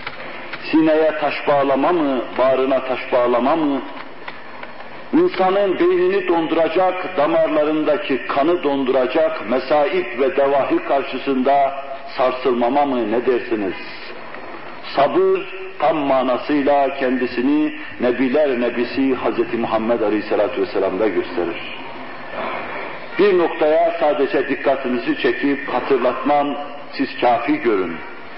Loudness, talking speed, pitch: -18 LUFS, 90 wpm, 150 Hz